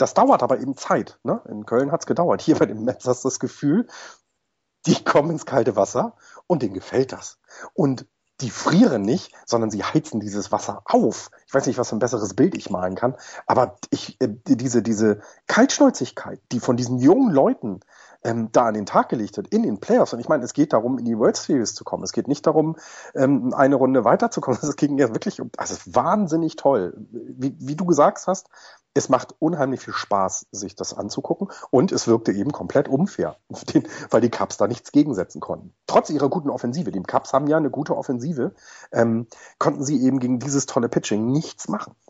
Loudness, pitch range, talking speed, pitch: -22 LUFS, 115-150 Hz, 200 wpm, 130 Hz